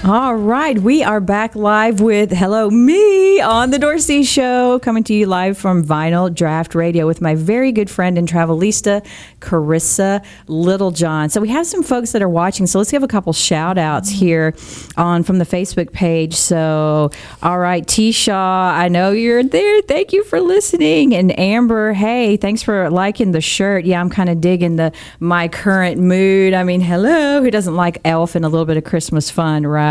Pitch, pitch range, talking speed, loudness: 190 Hz, 170-225 Hz, 195 wpm, -14 LUFS